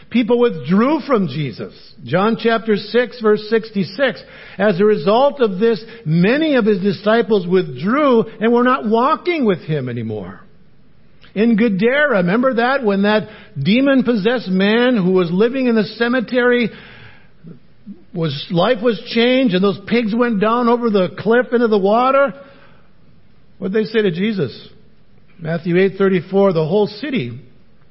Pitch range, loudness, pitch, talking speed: 190-240 Hz, -16 LUFS, 220 Hz, 140 wpm